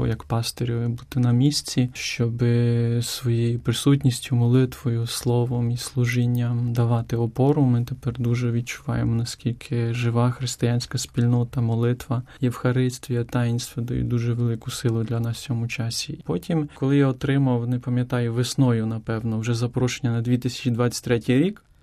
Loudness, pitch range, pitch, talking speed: -23 LUFS, 120-125 Hz, 120 Hz, 130 wpm